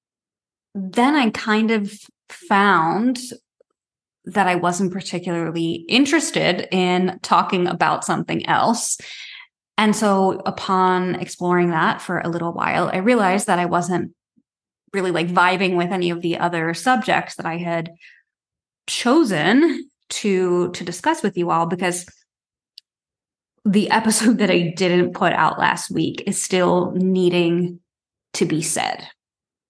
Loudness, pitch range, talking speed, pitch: -19 LUFS, 175-220 Hz, 130 wpm, 185 Hz